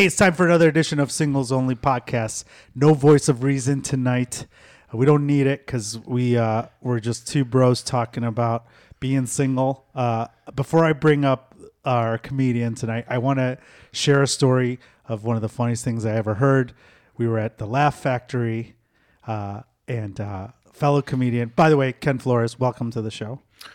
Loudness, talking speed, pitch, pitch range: -21 LUFS, 185 wpm, 125 Hz, 115-140 Hz